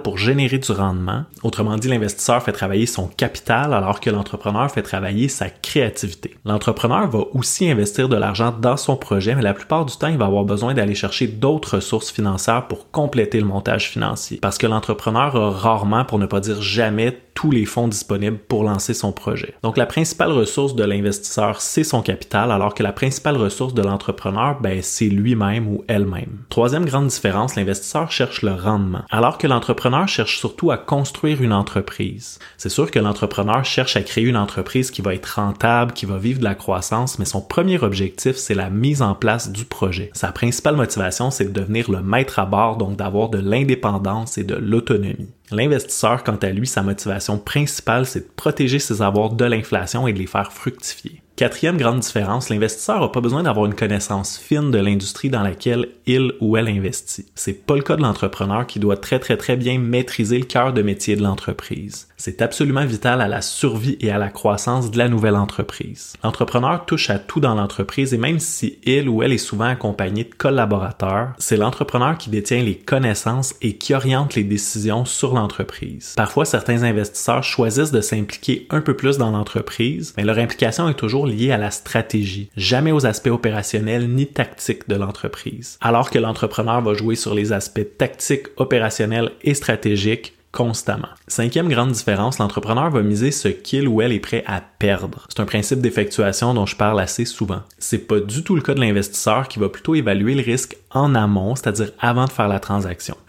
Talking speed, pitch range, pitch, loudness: 195 wpm, 100-130 Hz, 110 Hz, -19 LUFS